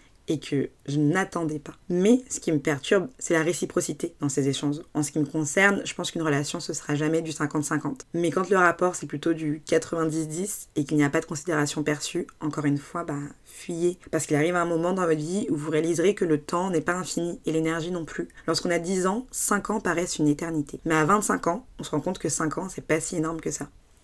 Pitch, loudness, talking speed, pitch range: 160 Hz, -26 LUFS, 250 wpm, 150-175 Hz